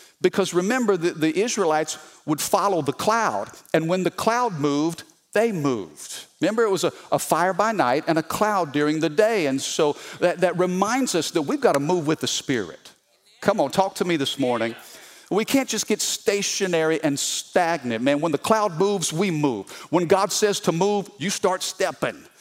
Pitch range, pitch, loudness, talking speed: 155-200 Hz, 180 Hz, -22 LUFS, 185 wpm